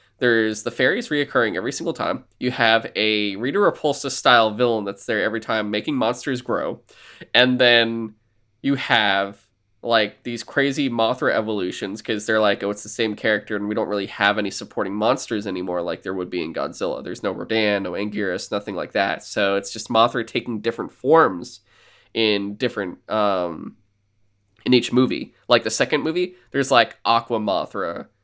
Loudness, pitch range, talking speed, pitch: -21 LUFS, 100-120 Hz, 175 wpm, 110 Hz